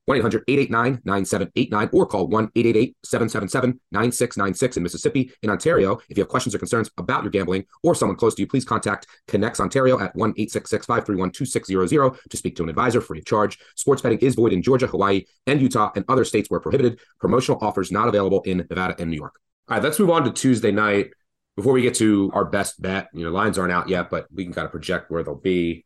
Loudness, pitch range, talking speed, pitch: -21 LUFS, 95-120 Hz, 225 wpm, 100 Hz